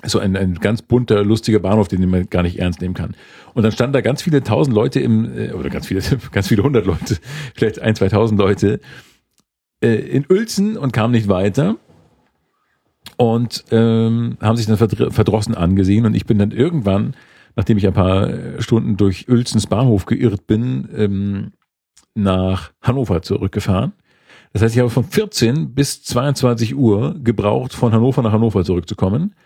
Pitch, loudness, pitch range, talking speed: 110 Hz, -17 LUFS, 100-125 Hz, 165 wpm